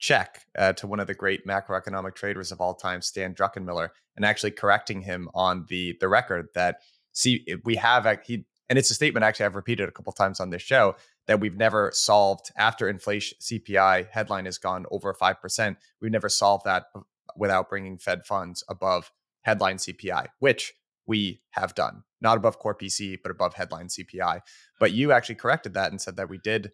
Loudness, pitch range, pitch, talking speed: -25 LUFS, 95-105 Hz, 100 Hz, 195 wpm